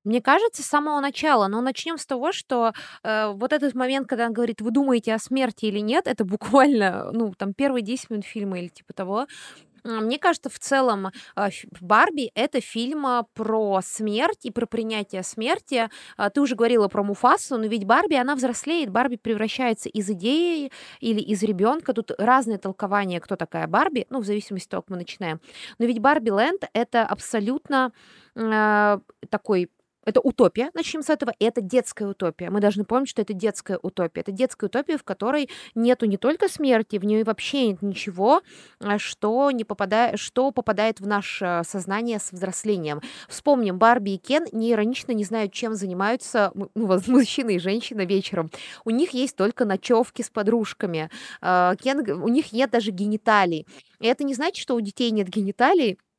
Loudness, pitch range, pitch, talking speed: -23 LUFS, 205-260 Hz, 225 Hz, 175 wpm